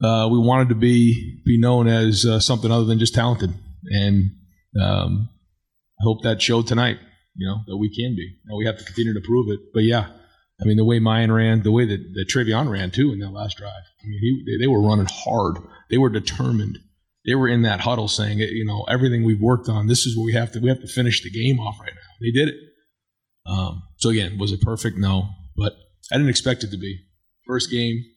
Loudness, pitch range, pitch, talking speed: -20 LUFS, 100-120 Hz, 110 Hz, 235 wpm